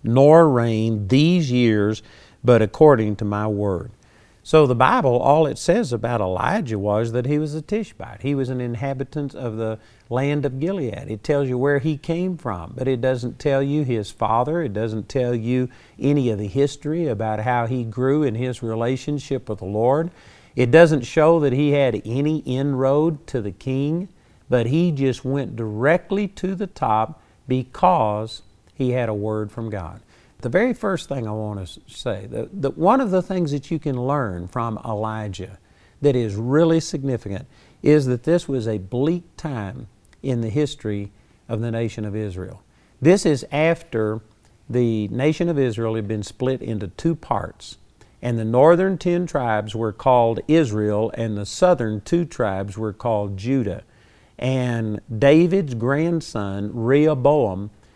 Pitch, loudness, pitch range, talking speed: 125 Hz, -21 LUFS, 110-145 Hz, 165 wpm